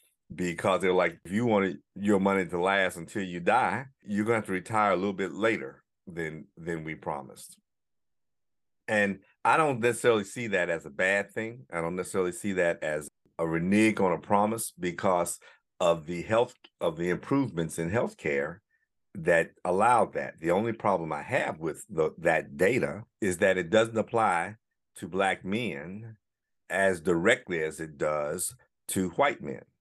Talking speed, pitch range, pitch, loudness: 175 wpm, 85-105 Hz, 95 Hz, -28 LUFS